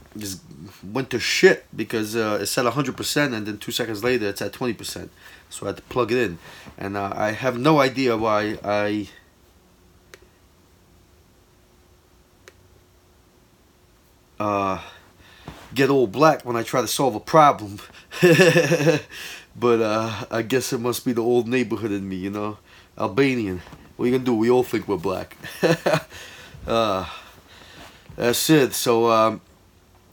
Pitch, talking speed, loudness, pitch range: 110 Hz, 150 wpm, -21 LUFS, 95-125 Hz